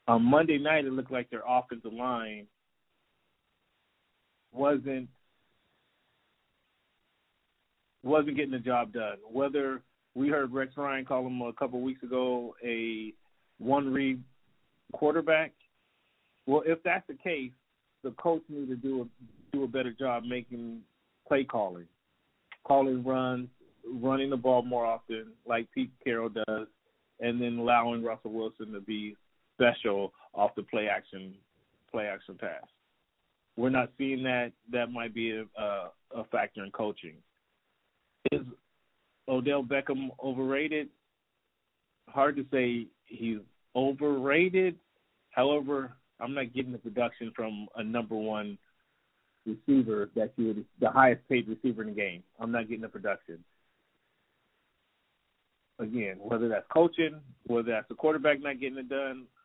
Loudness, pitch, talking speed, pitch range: -31 LUFS, 125 Hz, 135 wpm, 115-135 Hz